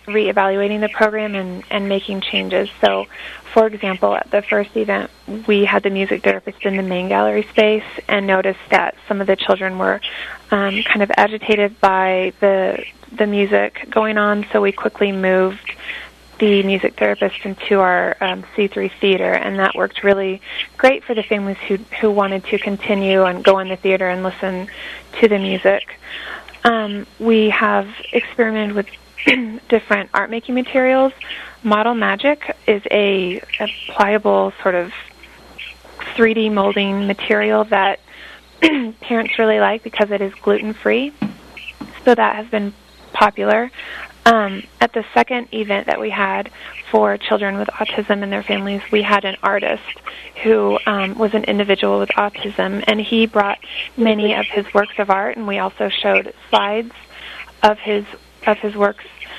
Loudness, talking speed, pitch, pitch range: -17 LUFS, 160 wpm, 205 Hz, 195-220 Hz